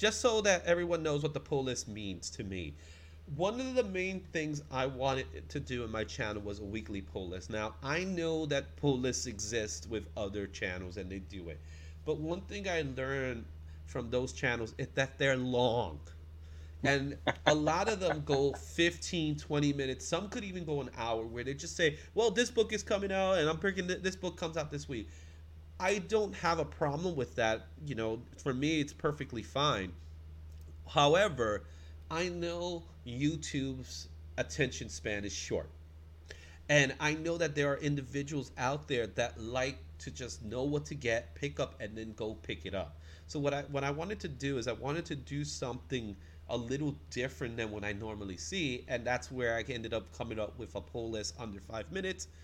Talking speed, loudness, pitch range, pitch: 200 wpm, -35 LUFS, 95-150 Hz, 125 Hz